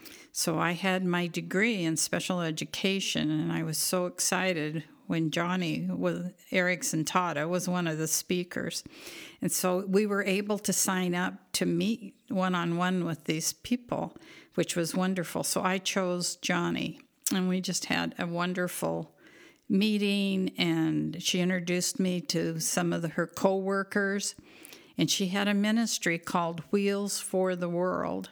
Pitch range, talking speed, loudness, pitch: 170-195 Hz, 150 wpm, -29 LUFS, 180 Hz